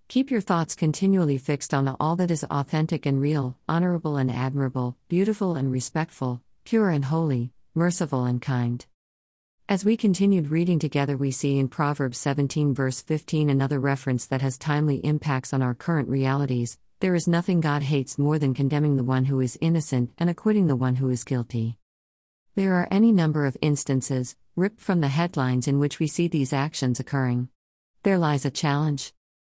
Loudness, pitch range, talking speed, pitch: -25 LUFS, 130-165 Hz, 175 wpm, 140 Hz